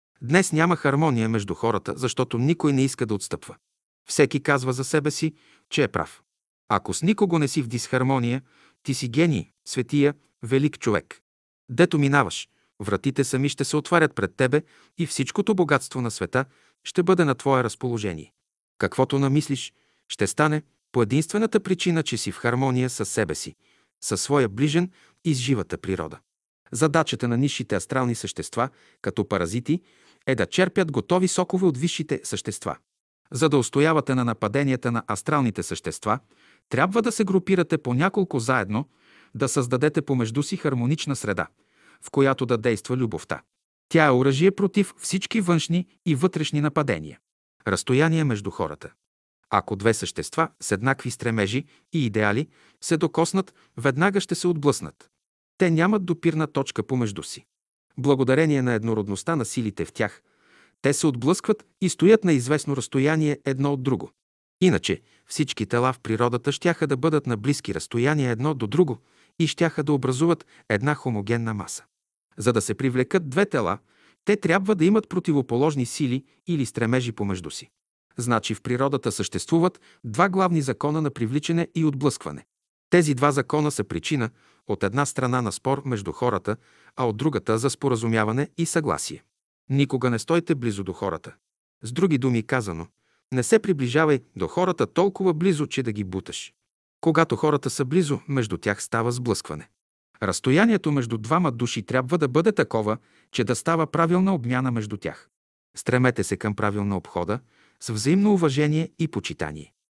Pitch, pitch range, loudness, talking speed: 135 Hz, 115-160 Hz, -24 LUFS, 155 wpm